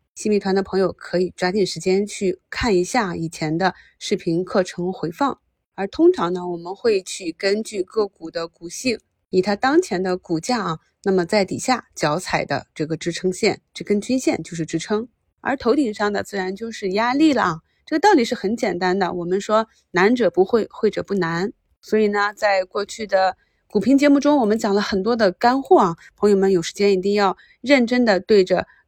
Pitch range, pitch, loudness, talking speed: 185-230 Hz, 200 Hz, -20 LUFS, 285 characters per minute